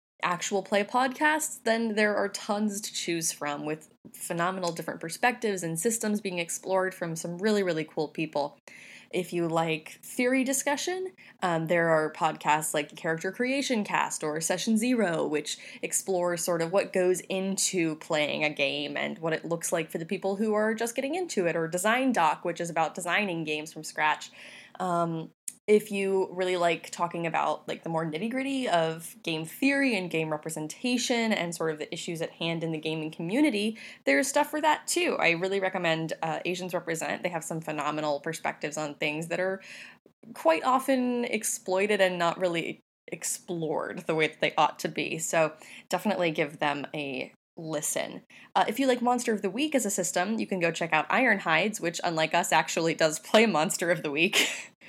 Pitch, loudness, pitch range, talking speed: 175 Hz, -28 LUFS, 160-215 Hz, 185 wpm